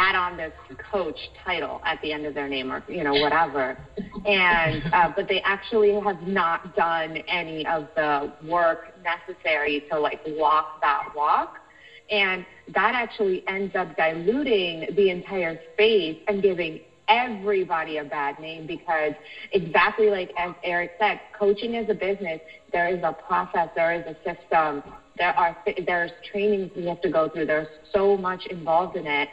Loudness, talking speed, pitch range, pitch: -24 LUFS, 165 wpm, 160-210 Hz, 180 Hz